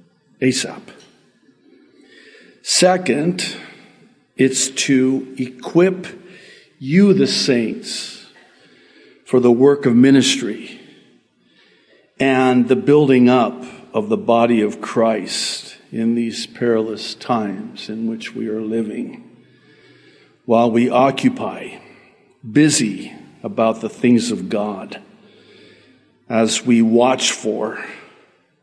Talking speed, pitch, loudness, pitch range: 90 wpm, 125 Hz, -17 LUFS, 115-135 Hz